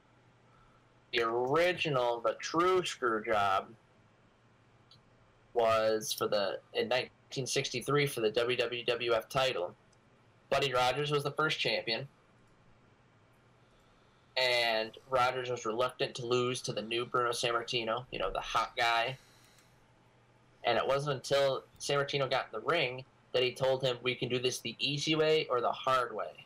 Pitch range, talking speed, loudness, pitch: 120-135 Hz, 135 wpm, -32 LUFS, 125 Hz